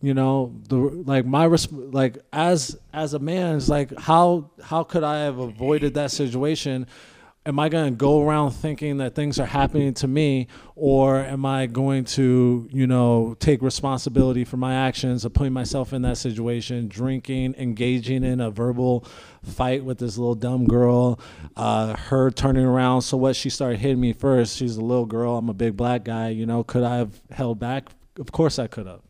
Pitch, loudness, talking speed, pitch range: 130 Hz, -22 LUFS, 190 wpm, 120-140 Hz